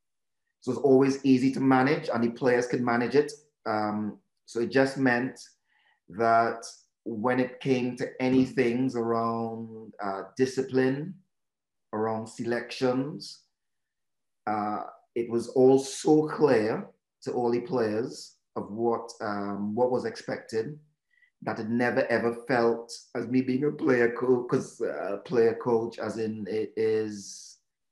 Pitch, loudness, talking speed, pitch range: 120 Hz, -27 LUFS, 140 wpm, 115-130 Hz